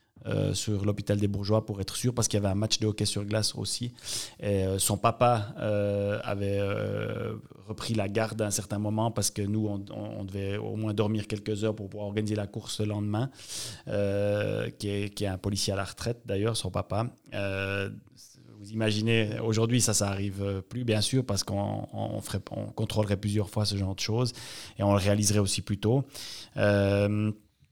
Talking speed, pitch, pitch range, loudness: 205 wpm, 105 Hz, 100-110 Hz, -29 LUFS